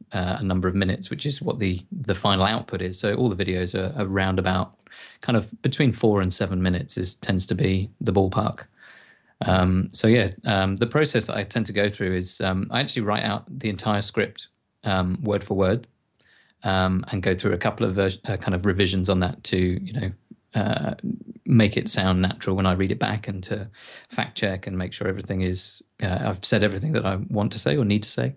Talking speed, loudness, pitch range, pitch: 225 wpm, -24 LUFS, 95-110 Hz, 95 Hz